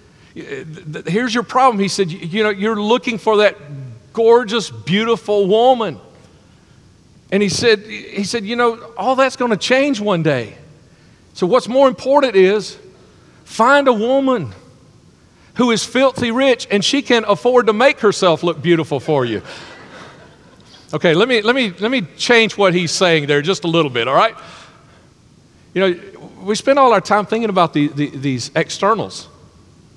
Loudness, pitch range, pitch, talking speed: -15 LUFS, 180-245 Hz, 215 Hz, 165 wpm